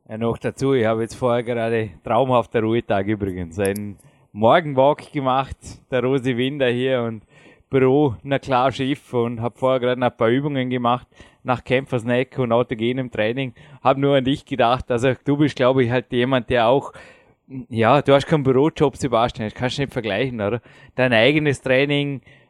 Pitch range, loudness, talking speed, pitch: 115-135 Hz, -20 LUFS, 175 wpm, 125 Hz